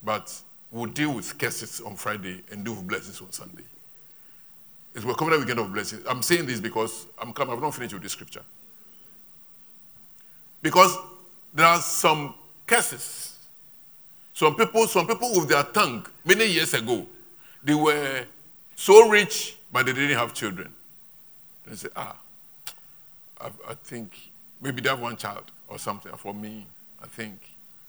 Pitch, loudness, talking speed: 115 Hz, -23 LUFS, 155 wpm